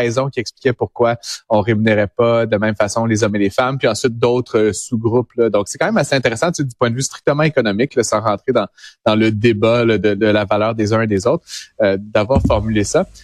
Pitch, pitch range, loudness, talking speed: 115 Hz, 105-125 Hz, -16 LUFS, 245 wpm